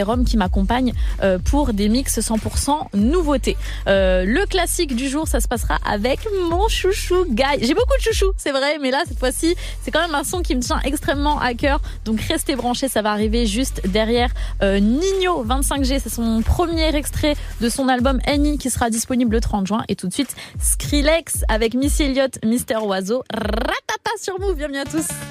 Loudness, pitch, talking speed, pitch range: -20 LUFS, 270 Hz, 190 wpm, 230-315 Hz